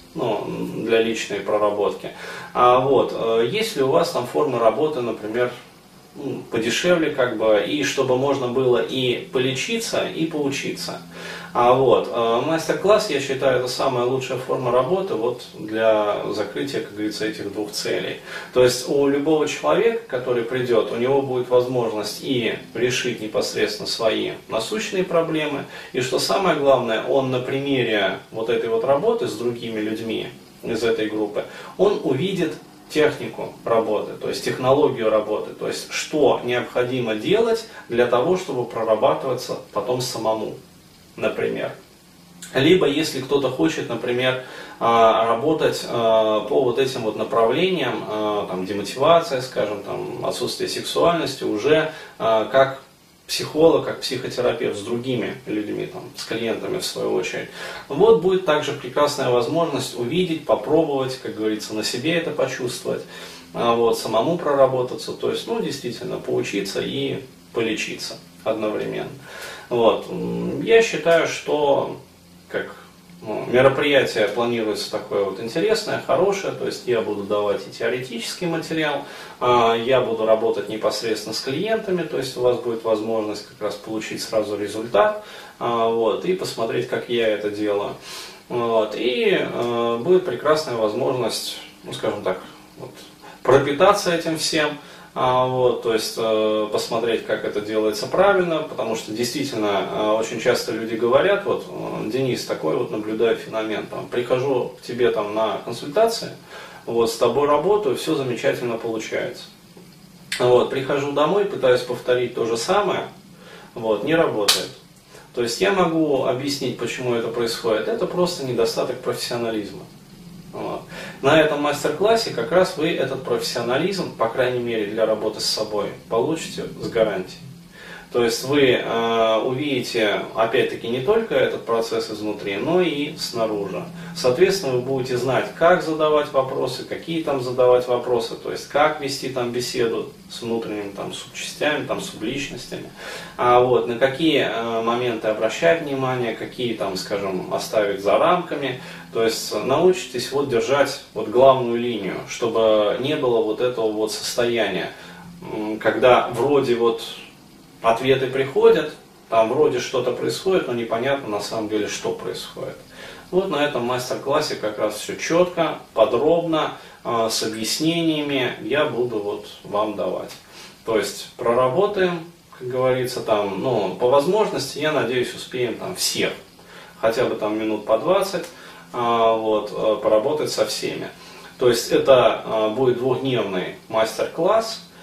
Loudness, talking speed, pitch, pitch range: -21 LUFS, 135 wpm, 130 Hz, 115-165 Hz